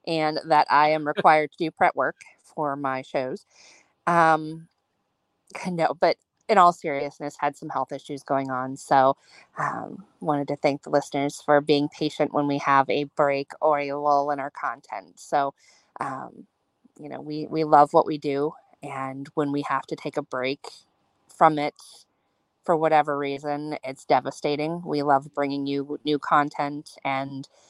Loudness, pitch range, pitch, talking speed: -24 LUFS, 140-155 Hz, 145 Hz, 165 wpm